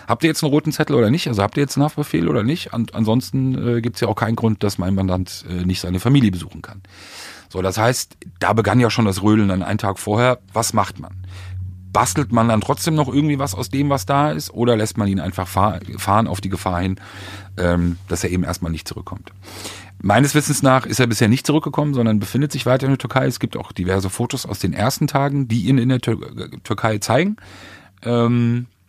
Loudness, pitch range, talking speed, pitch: -19 LUFS, 95-130 Hz, 235 wpm, 110 Hz